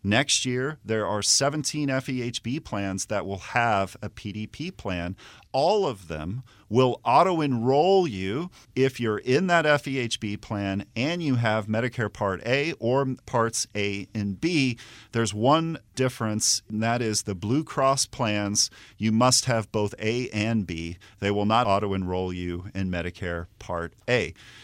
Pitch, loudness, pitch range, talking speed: 110 Hz, -25 LUFS, 100-130 Hz, 155 wpm